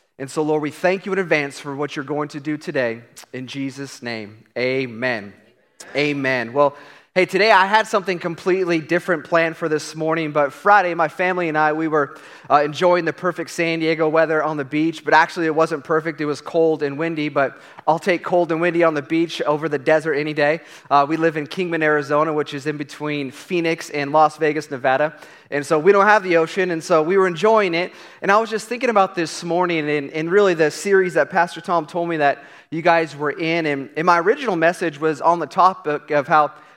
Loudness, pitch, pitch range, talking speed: -19 LUFS, 160 Hz, 150-170 Hz, 220 wpm